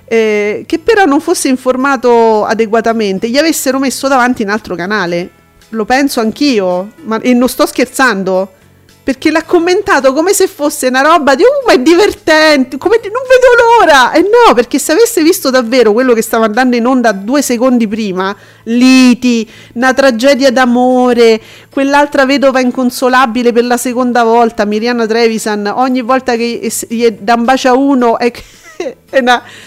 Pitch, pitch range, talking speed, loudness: 255 Hz, 230-285 Hz, 170 wpm, -9 LUFS